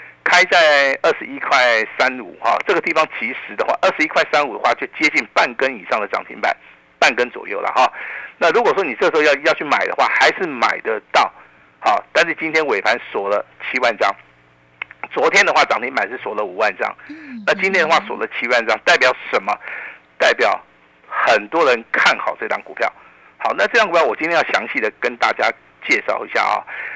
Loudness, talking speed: -17 LUFS, 300 characters per minute